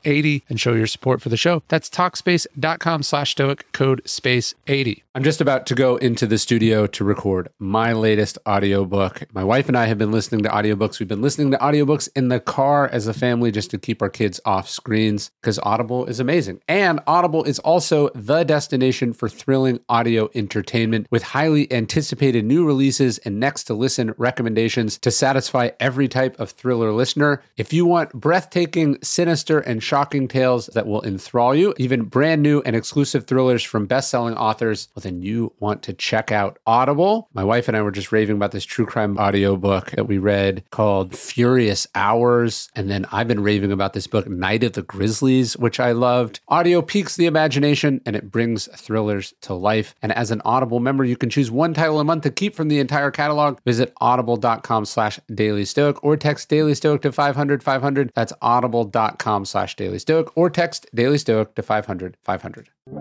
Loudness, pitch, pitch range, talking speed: -20 LUFS, 125 Hz, 110-145 Hz, 185 wpm